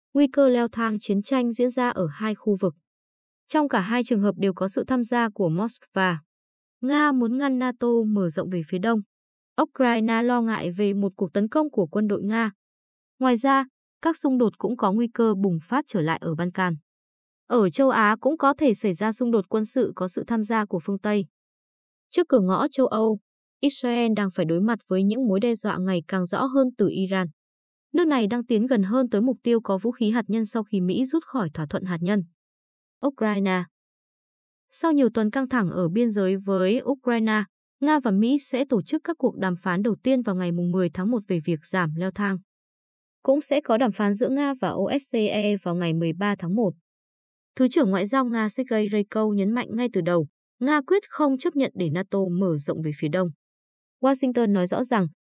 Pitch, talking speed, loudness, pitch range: 220 Hz, 215 wpm, -24 LUFS, 190-255 Hz